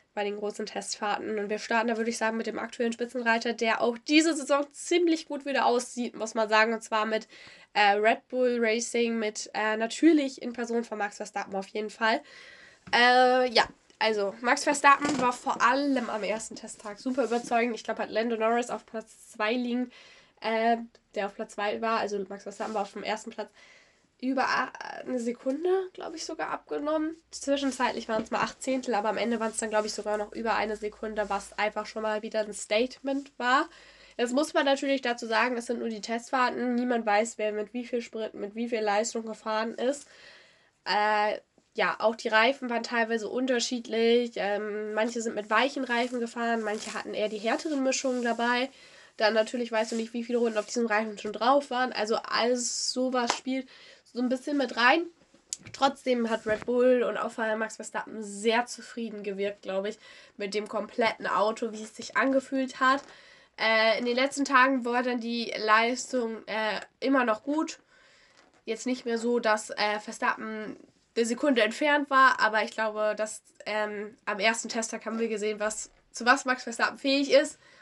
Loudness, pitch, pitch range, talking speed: -28 LUFS, 230 Hz, 215-255 Hz, 190 wpm